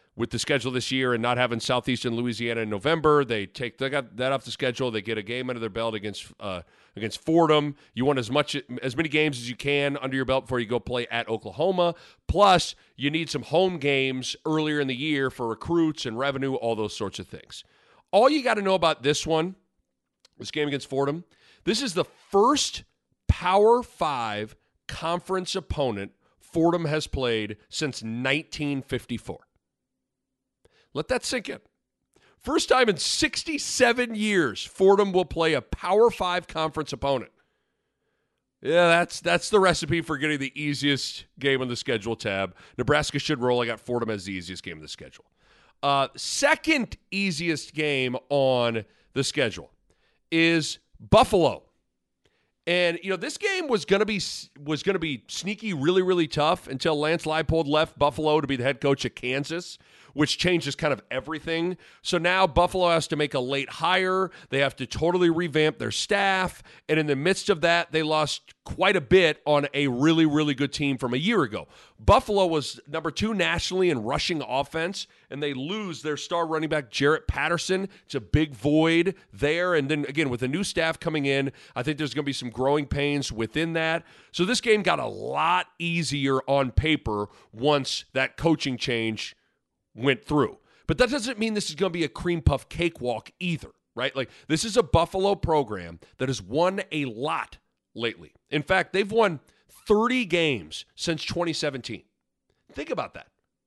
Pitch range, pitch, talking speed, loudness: 130-170 Hz, 150 Hz, 180 wpm, -25 LUFS